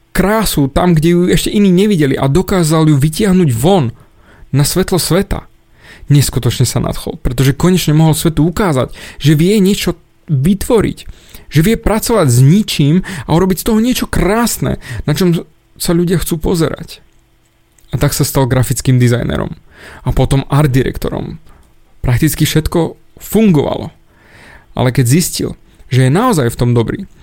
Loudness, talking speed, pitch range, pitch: -12 LUFS, 145 wpm, 135-185 Hz, 155 Hz